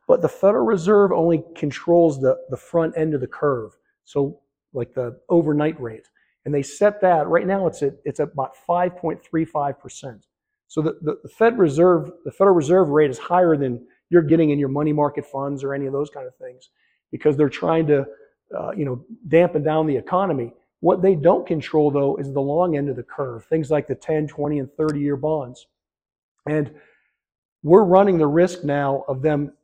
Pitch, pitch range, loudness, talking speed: 150 Hz, 140-175 Hz, -20 LUFS, 195 wpm